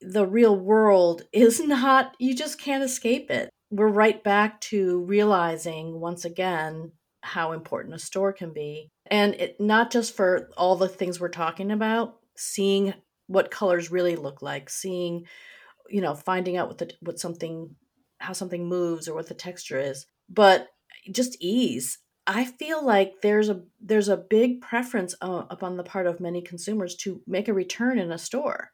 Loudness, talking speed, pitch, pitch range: -25 LUFS, 170 wpm, 190 Hz, 175-220 Hz